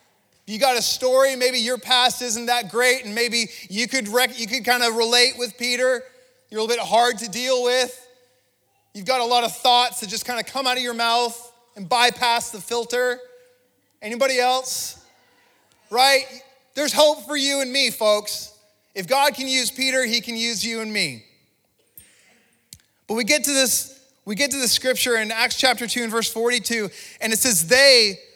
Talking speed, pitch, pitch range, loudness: 190 wpm, 245 Hz, 230-255 Hz, -19 LUFS